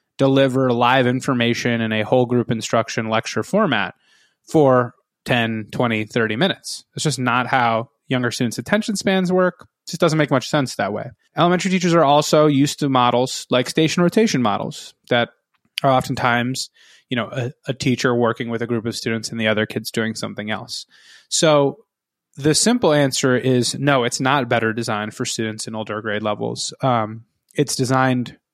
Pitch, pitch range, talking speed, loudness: 125 Hz, 115-145 Hz, 175 wpm, -19 LUFS